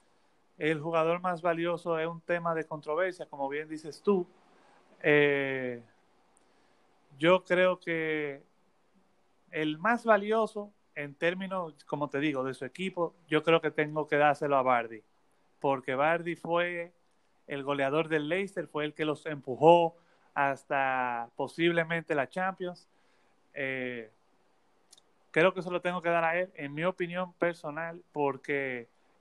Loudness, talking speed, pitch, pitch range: -30 LUFS, 140 wpm, 160 Hz, 140-175 Hz